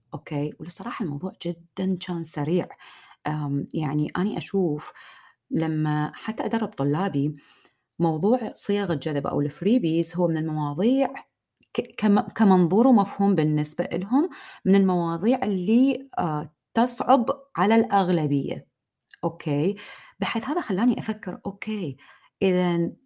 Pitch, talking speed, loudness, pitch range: 185 Hz, 95 wpm, -24 LUFS, 155-220 Hz